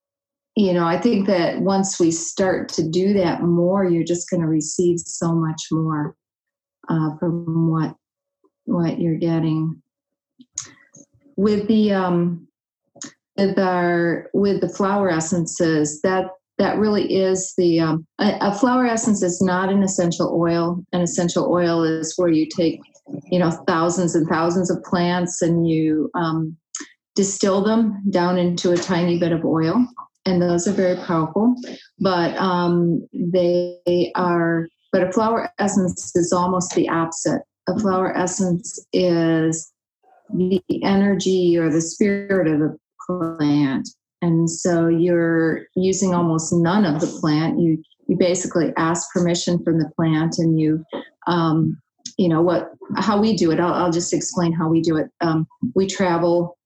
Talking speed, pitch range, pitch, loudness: 150 wpm, 165-195 Hz, 175 Hz, -20 LUFS